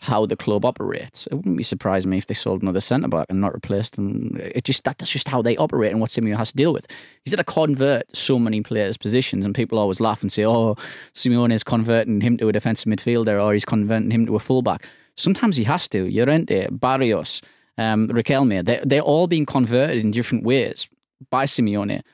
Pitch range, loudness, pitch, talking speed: 105-130 Hz, -21 LUFS, 115 Hz, 220 wpm